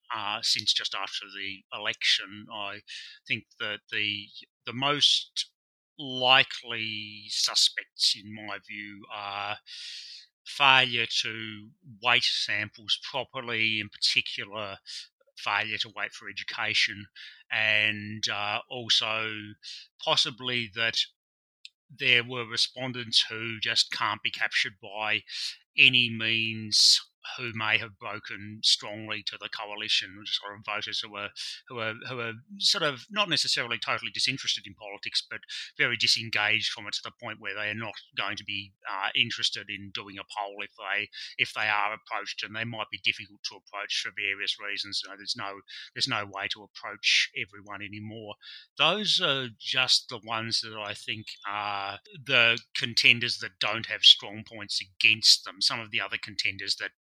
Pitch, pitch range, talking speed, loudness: 110 Hz, 105-120 Hz, 150 wpm, -26 LUFS